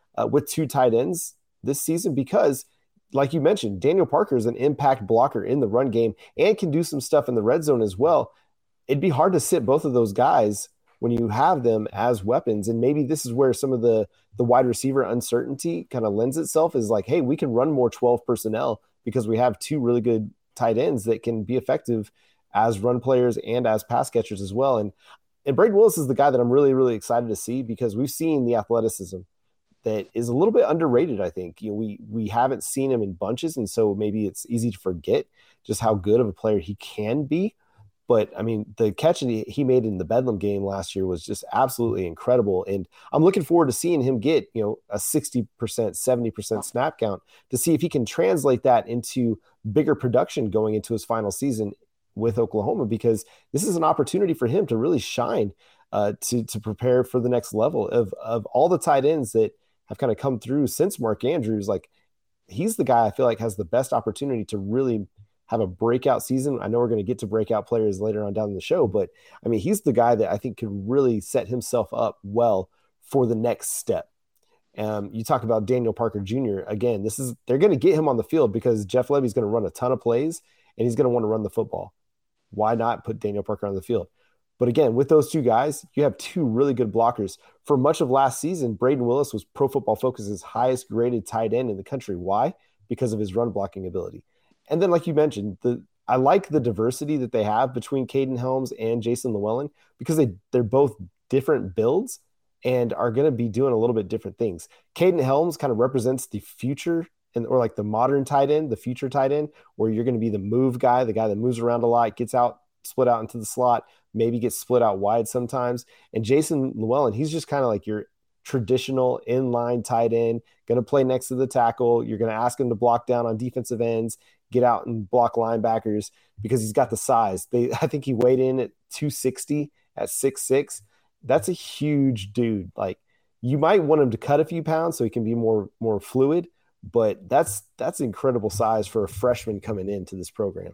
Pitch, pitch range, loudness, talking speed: 120 Hz, 110-135 Hz, -23 LUFS, 225 wpm